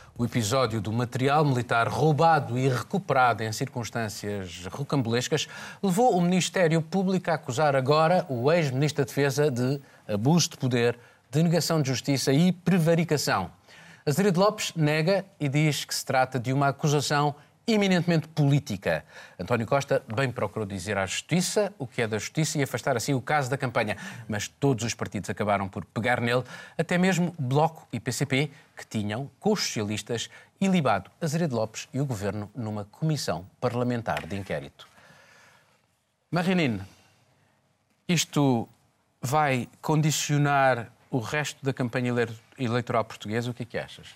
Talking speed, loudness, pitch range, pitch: 145 wpm, -26 LUFS, 120-155 Hz, 135 Hz